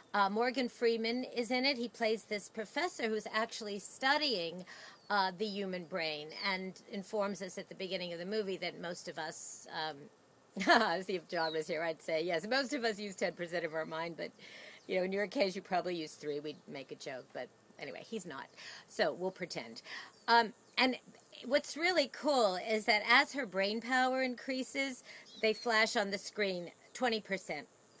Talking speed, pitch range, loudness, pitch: 185 wpm, 175-235 Hz, -35 LUFS, 205 Hz